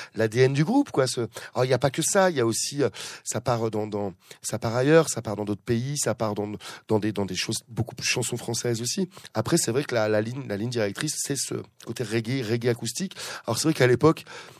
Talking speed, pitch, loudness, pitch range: 250 wpm, 120 Hz, -26 LUFS, 110-140 Hz